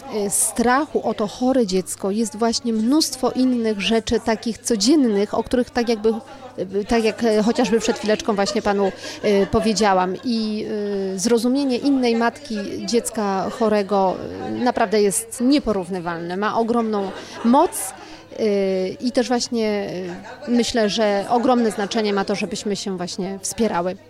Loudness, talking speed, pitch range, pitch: -20 LUFS, 120 wpm, 200-240 Hz, 220 Hz